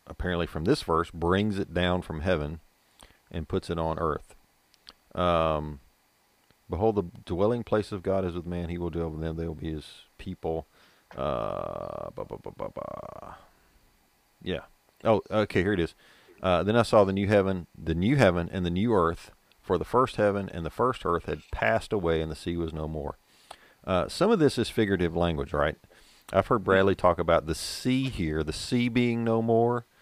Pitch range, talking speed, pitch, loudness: 80-105 Hz, 195 wpm, 90 Hz, -28 LUFS